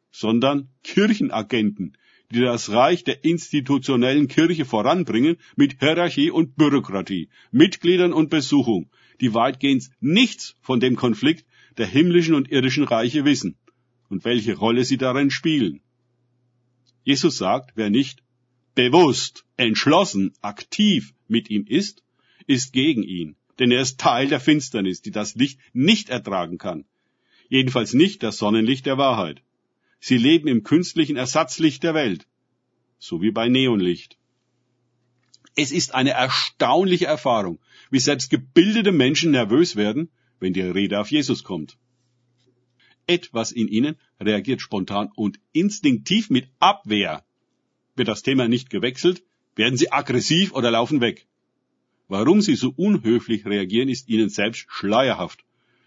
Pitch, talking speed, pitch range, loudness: 130 Hz, 130 wpm, 120-155 Hz, -20 LUFS